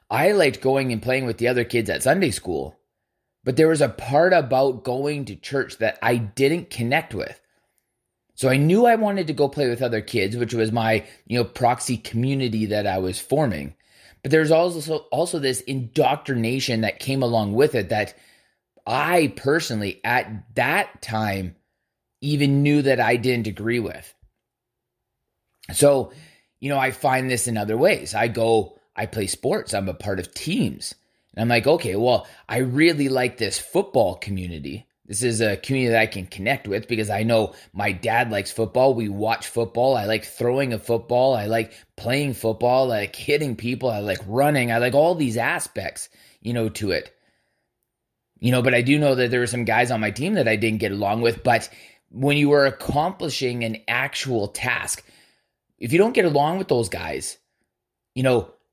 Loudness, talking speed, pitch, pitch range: -22 LUFS, 190 wpm, 120 Hz, 110-135 Hz